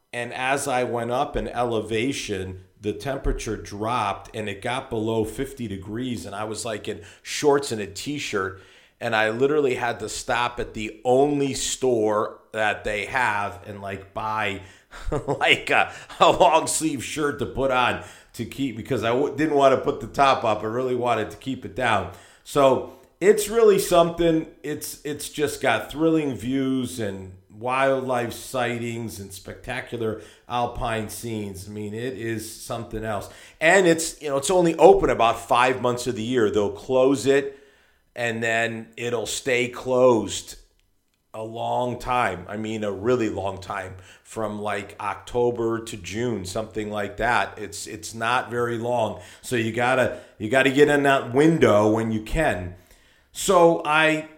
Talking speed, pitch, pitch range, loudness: 165 wpm, 120 Hz, 105-135 Hz, -23 LUFS